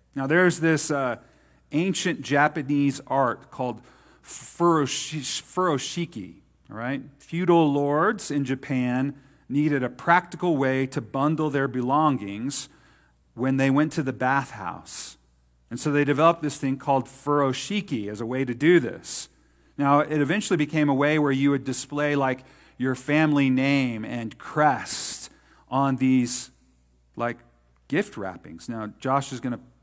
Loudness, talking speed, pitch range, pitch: -24 LUFS, 140 wpm, 125-150 Hz, 140 Hz